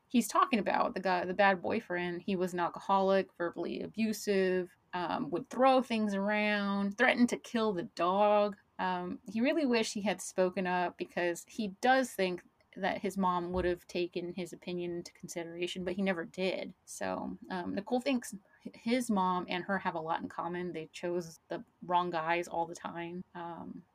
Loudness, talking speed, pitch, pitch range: -33 LUFS, 180 wpm, 185 Hz, 175-210 Hz